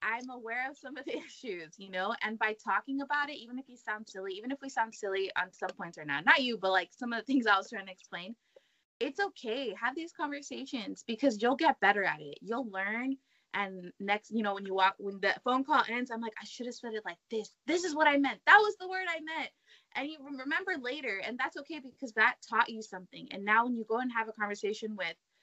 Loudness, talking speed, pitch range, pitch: -32 LUFS, 255 wpm, 200-270 Hz, 230 Hz